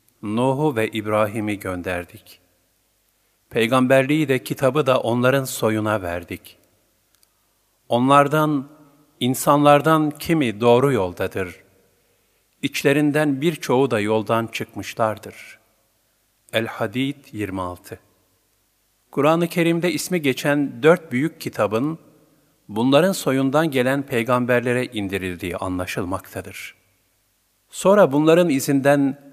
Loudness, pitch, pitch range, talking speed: -20 LUFS, 120 Hz, 105-145 Hz, 80 wpm